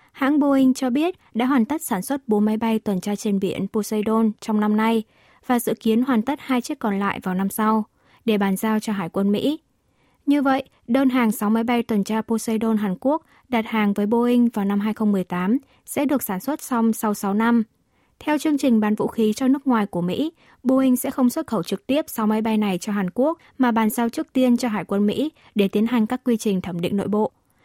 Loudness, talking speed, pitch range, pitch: -22 LUFS, 240 wpm, 210-260 Hz, 225 Hz